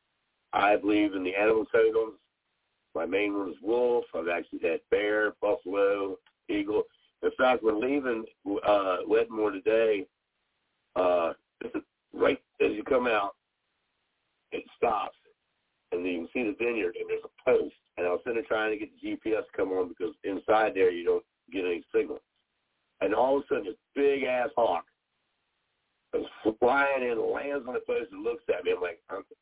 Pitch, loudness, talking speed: 365 Hz, -29 LUFS, 175 wpm